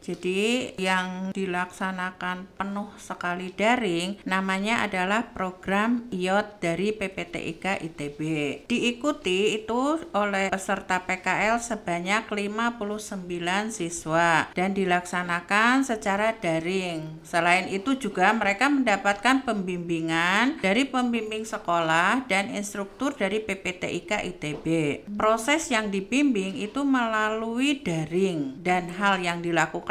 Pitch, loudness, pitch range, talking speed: 195 Hz, -26 LUFS, 180-220 Hz, 100 wpm